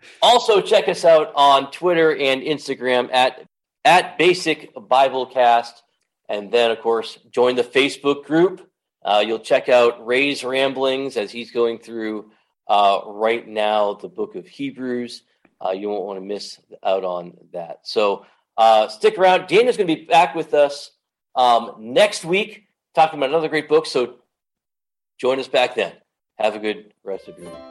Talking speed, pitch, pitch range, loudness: 165 wpm, 130 Hz, 115-155 Hz, -19 LUFS